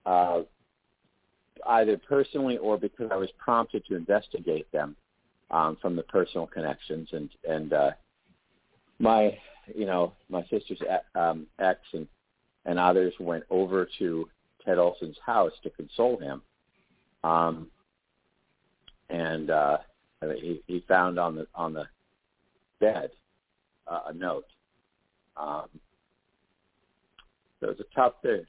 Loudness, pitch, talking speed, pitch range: -28 LUFS, 85 Hz, 125 wpm, 80-95 Hz